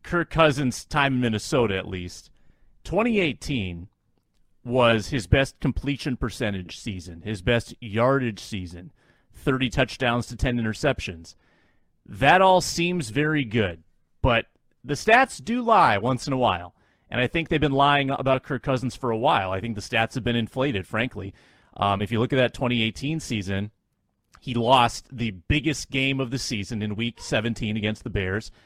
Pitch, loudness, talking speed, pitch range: 120 Hz, -24 LUFS, 165 wpm, 105-135 Hz